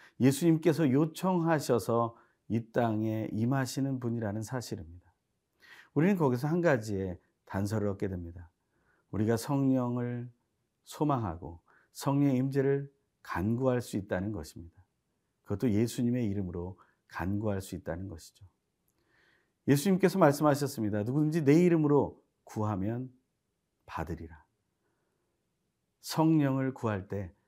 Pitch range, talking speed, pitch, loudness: 100-140 Hz, 275 characters per minute, 115 Hz, -30 LUFS